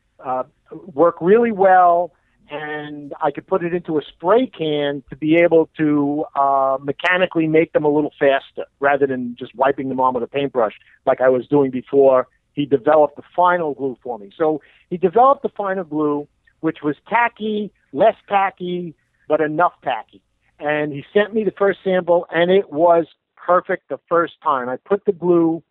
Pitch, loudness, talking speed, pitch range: 155 Hz, -18 LUFS, 180 wpm, 140-180 Hz